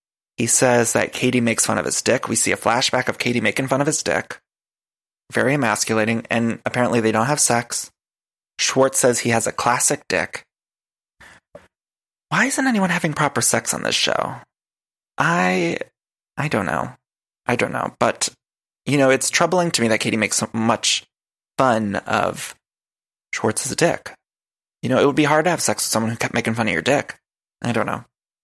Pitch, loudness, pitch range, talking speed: 120 Hz, -19 LUFS, 110-140 Hz, 185 wpm